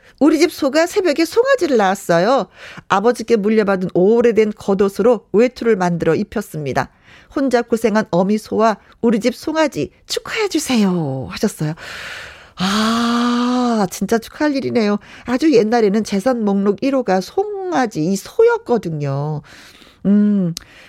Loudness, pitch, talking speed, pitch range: -17 LUFS, 225 Hz, 285 characters per minute, 195-255 Hz